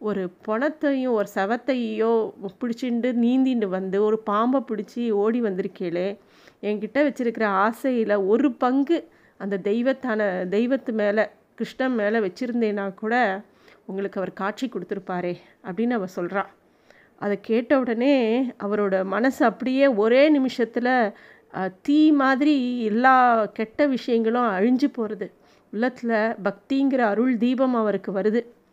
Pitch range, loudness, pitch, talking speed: 205-255 Hz, -23 LUFS, 225 Hz, 110 wpm